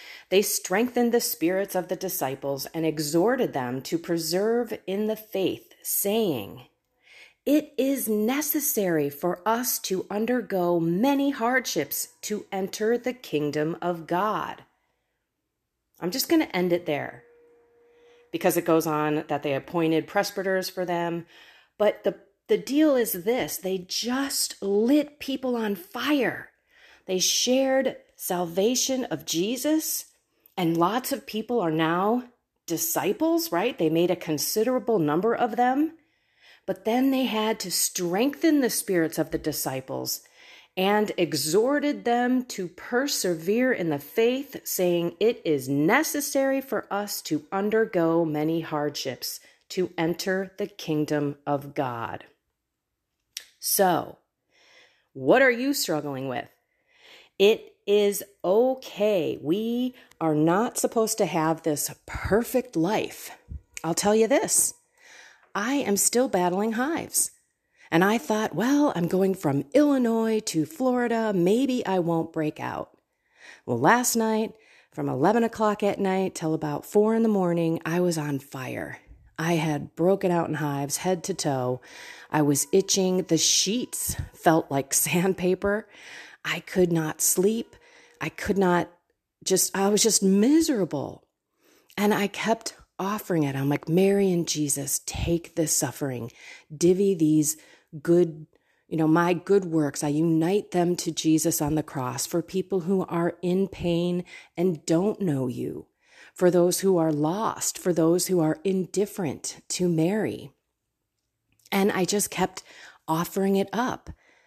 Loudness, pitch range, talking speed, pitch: -25 LUFS, 165-230 Hz, 140 wpm, 190 Hz